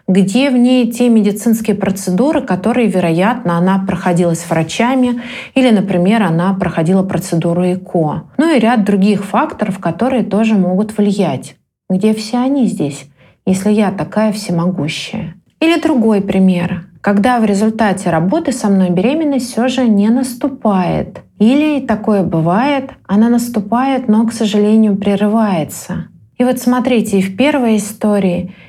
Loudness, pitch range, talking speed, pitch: -13 LUFS, 185-240 Hz, 135 wpm, 210 Hz